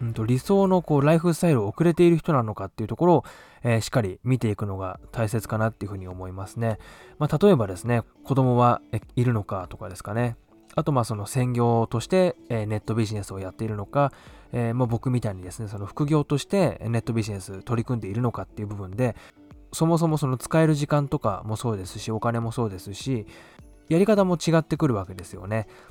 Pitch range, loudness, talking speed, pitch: 105-145 Hz, -25 LUFS, 430 characters per minute, 115 Hz